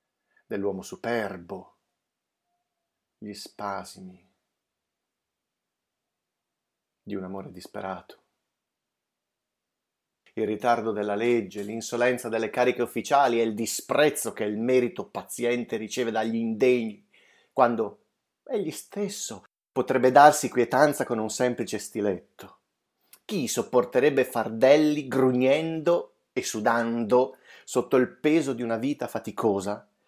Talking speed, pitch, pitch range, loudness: 100 wpm, 120 Hz, 110-130 Hz, -25 LUFS